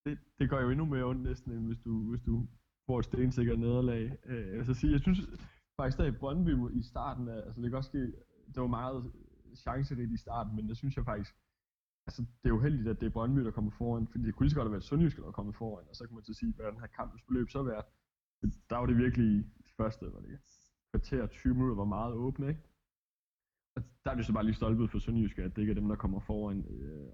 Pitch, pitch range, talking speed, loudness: 115 Hz, 110-130 Hz, 260 wpm, -35 LUFS